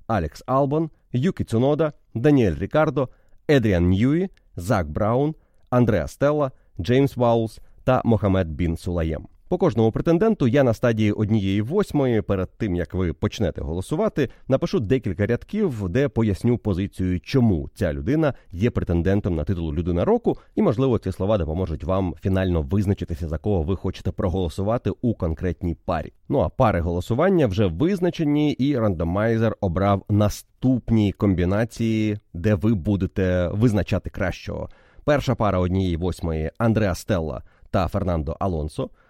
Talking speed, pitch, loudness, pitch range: 135 wpm, 105 Hz, -23 LUFS, 90-125 Hz